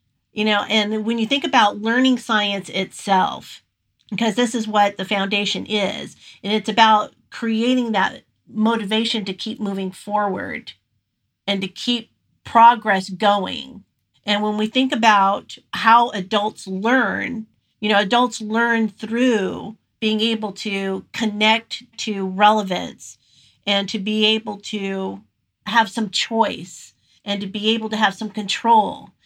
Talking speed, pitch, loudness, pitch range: 135 wpm, 215 Hz, -19 LUFS, 195-225 Hz